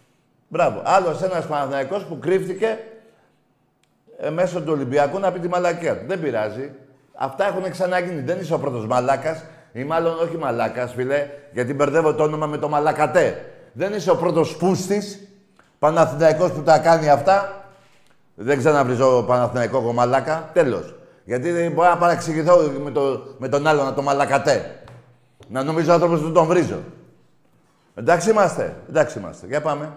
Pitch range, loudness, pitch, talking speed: 140-180 Hz, -20 LUFS, 160 Hz, 155 wpm